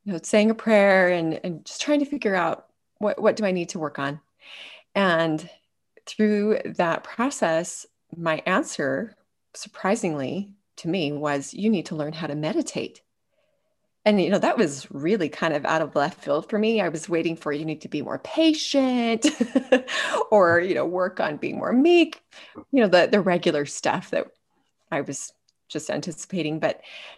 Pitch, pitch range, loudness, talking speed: 195 Hz, 165-240 Hz, -23 LUFS, 180 wpm